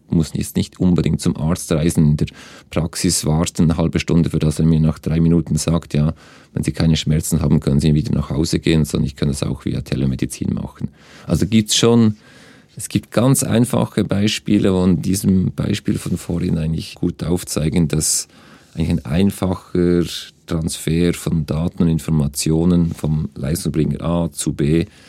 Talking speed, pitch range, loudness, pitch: 180 wpm, 75-90 Hz, -18 LUFS, 80 Hz